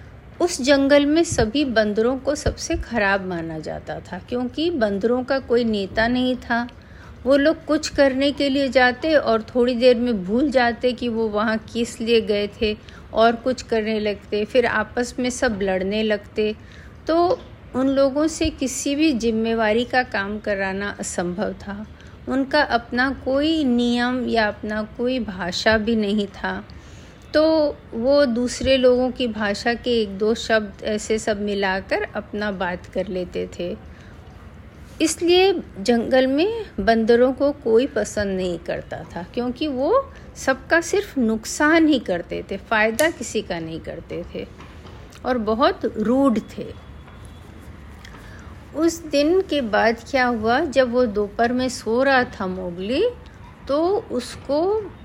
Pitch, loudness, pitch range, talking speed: 240 Hz, -21 LUFS, 210-275 Hz, 145 wpm